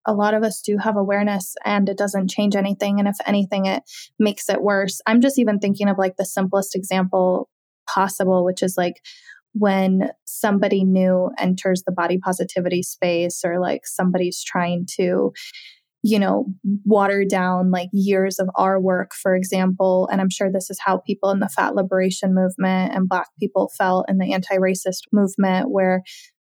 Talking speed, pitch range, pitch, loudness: 175 wpm, 185-200 Hz, 190 Hz, -20 LUFS